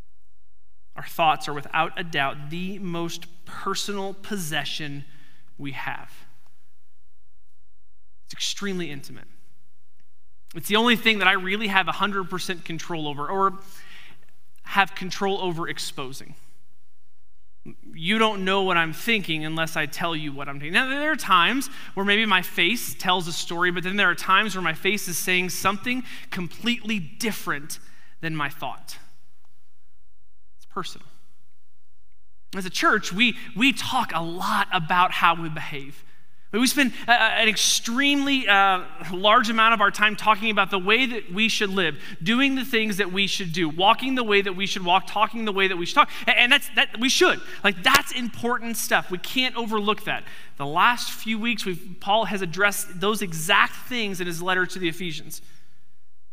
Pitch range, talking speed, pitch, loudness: 150-215 Hz, 165 wpm, 185 Hz, -22 LUFS